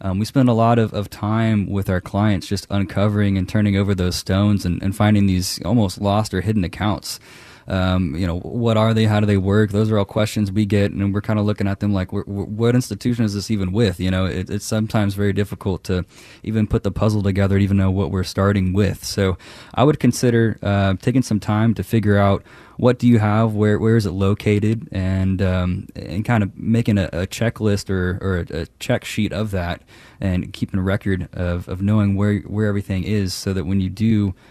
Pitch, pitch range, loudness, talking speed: 100 Hz, 95-110 Hz, -20 LUFS, 230 wpm